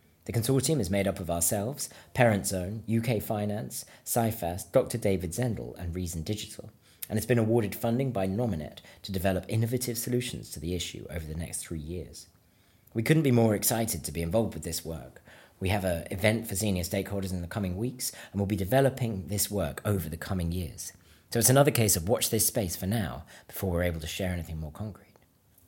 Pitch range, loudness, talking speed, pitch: 85-115 Hz, -29 LUFS, 200 wpm, 100 Hz